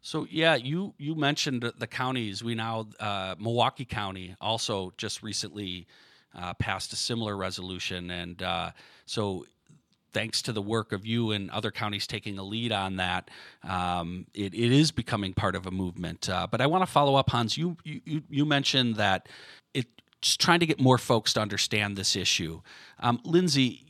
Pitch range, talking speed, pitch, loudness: 95-130 Hz, 180 wpm, 110 Hz, -28 LUFS